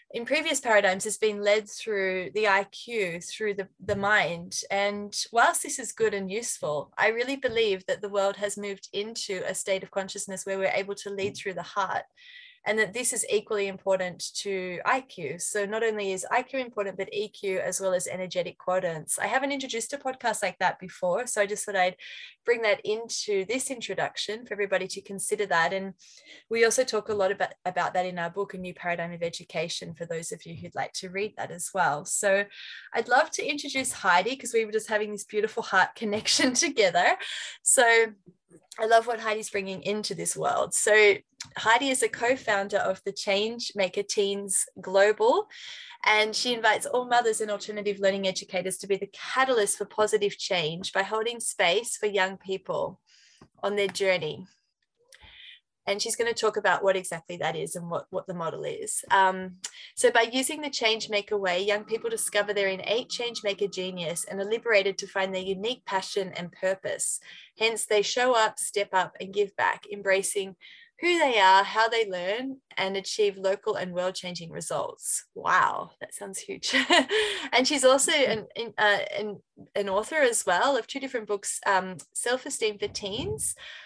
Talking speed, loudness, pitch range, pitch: 185 wpm, -27 LUFS, 190-235 Hz, 205 Hz